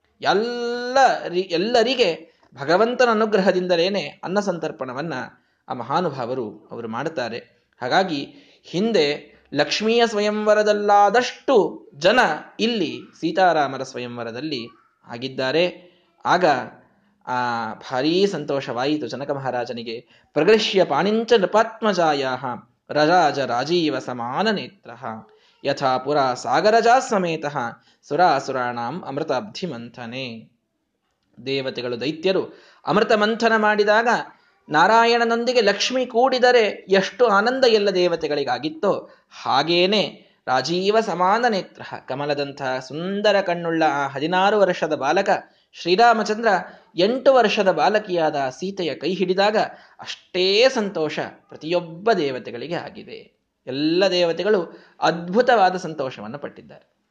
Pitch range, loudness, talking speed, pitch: 145-220 Hz, -20 LUFS, 80 wpm, 185 Hz